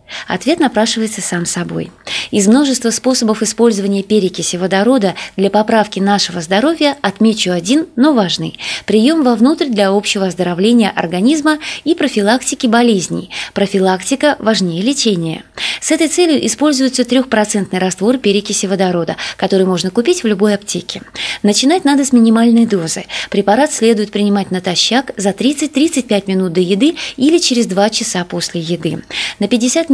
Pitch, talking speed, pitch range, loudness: 215 Hz, 130 wpm, 195-260 Hz, -13 LUFS